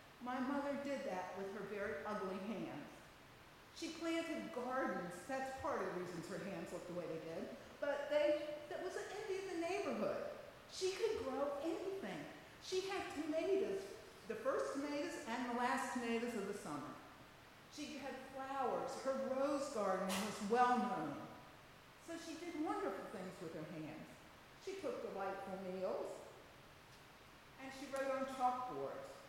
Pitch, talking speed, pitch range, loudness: 265 Hz, 155 wpm, 205-320 Hz, -43 LUFS